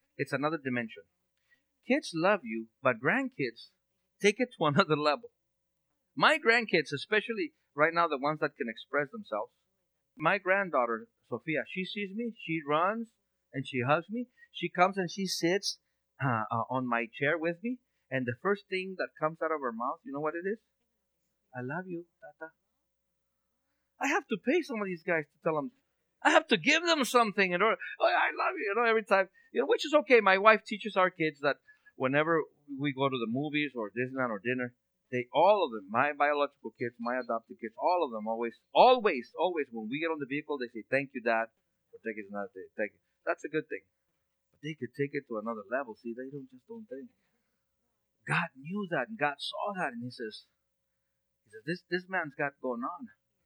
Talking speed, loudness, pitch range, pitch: 205 wpm, -31 LUFS, 130-210 Hz, 160 Hz